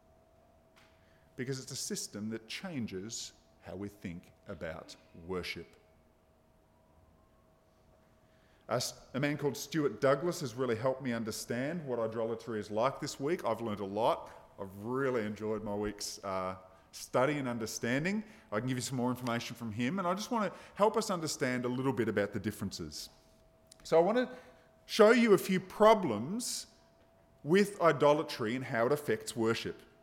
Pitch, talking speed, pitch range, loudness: 115 Hz, 160 wpm, 100-145 Hz, -33 LUFS